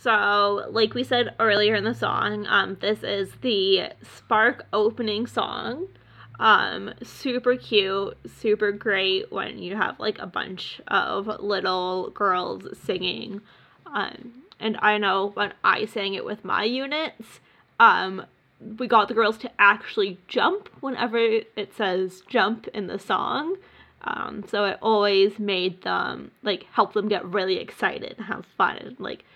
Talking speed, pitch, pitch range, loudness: 145 wpm, 215 Hz, 200-240 Hz, -24 LUFS